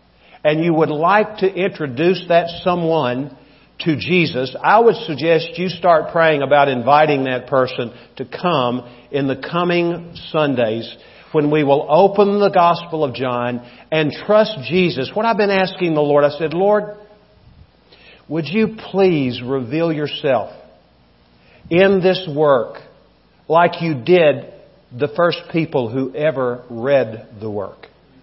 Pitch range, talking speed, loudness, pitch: 130-180 Hz, 140 wpm, -17 LUFS, 155 Hz